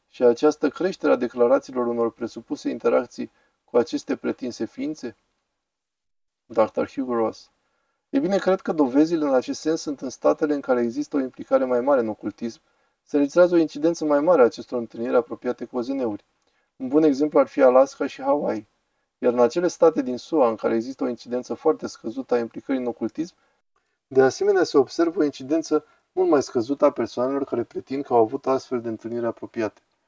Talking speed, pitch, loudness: 185 wpm, 150 Hz, -23 LUFS